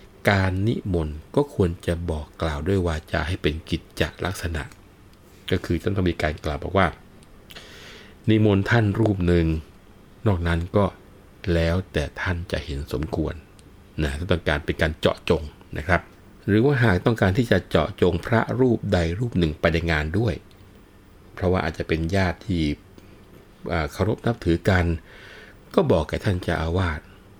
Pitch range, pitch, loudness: 85-100 Hz, 90 Hz, -24 LUFS